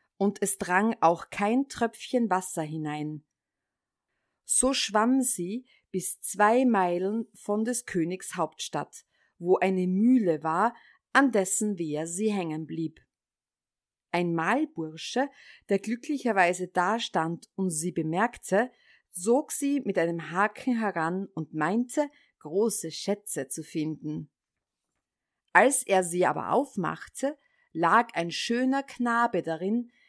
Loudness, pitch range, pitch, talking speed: -27 LUFS, 170-235 Hz, 200 Hz, 120 wpm